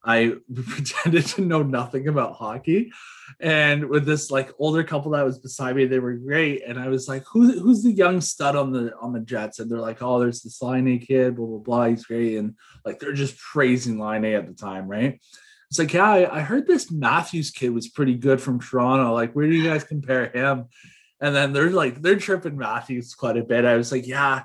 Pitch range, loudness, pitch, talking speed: 120-150 Hz, -22 LUFS, 135 Hz, 230 wpm